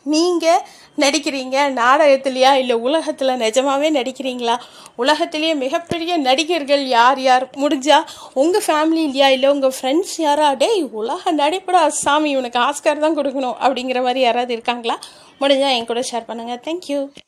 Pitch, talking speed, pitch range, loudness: 280 Hz, 130 wpm, 255-310 Hz, -17 LUFS